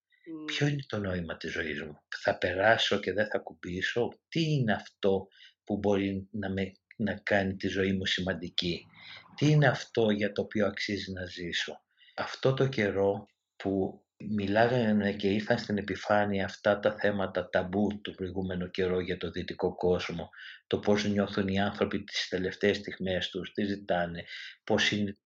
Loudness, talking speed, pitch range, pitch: -30 LUFS, 160 wpm, 95-105 Hz, 100 Hz